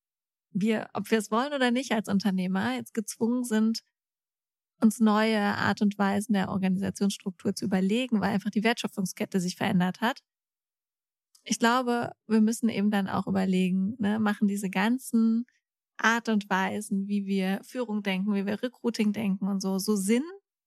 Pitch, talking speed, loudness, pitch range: 210 Hz, 160 wpm, -27 LUFS, 195-225 Hz